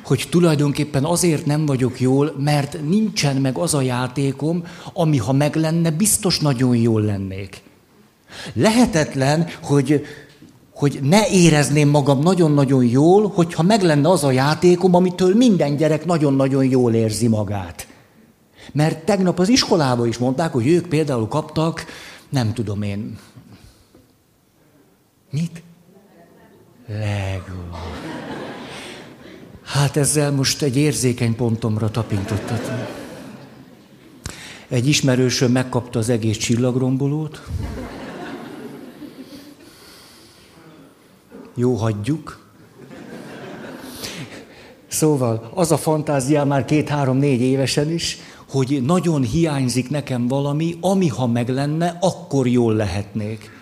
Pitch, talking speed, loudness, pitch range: 145 Hz, 100 wpm, -18 LUFS, 125-165 Hz